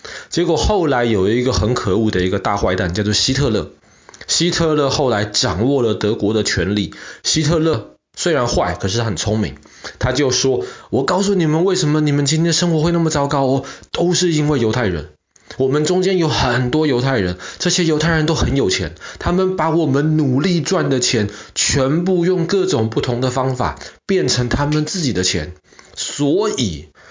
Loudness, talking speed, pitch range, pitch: -17 LUFS, 275 characters per minute, 105-160 Hz, 130 Hz